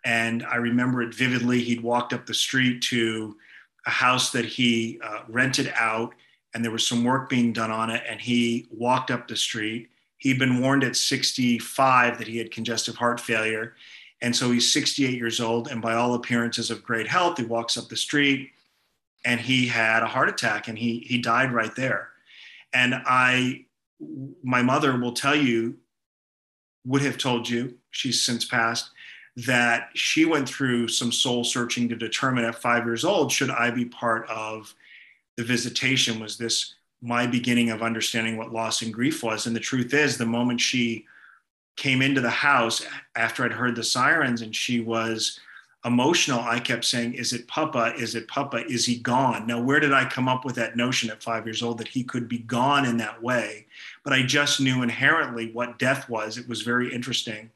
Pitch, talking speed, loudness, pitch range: 120 Hz, 190 wpm, -24 LUFS, 115-125 Hz